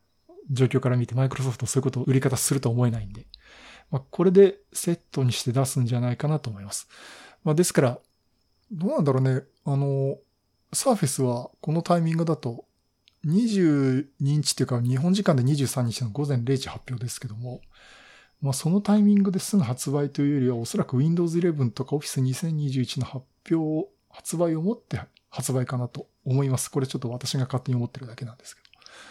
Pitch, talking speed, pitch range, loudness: 135 Hz, 385 characters per minute, 125-160 Hz, -25 LUFS